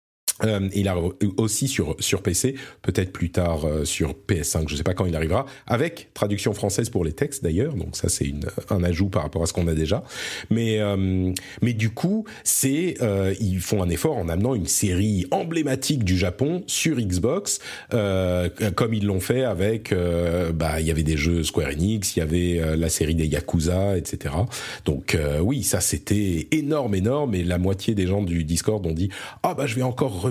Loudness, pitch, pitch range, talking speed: -24 LUFS, 95 Hz, 85-110 Hz, 210 wpm